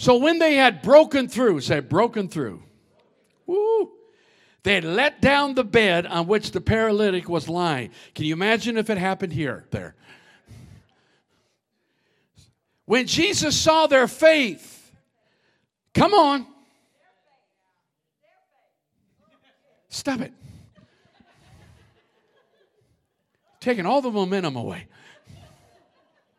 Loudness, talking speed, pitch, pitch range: -21 LUFS, 100 wpm, 225 Hz, 175-285 Hz